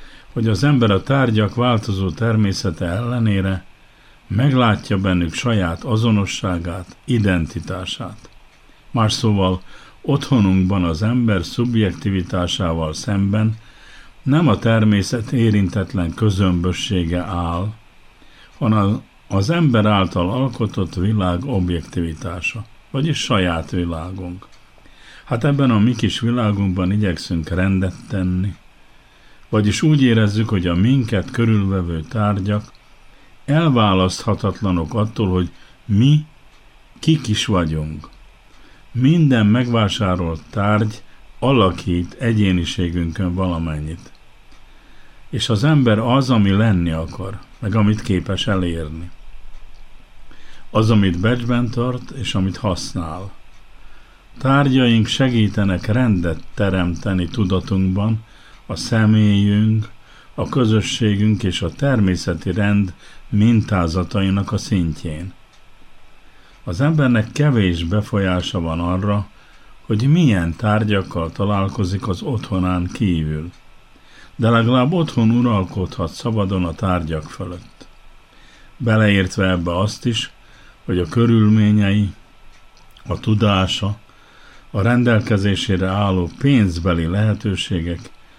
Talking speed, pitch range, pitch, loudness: 90 wpm, 90-115 Hz, 100 Hz, -18 LUFS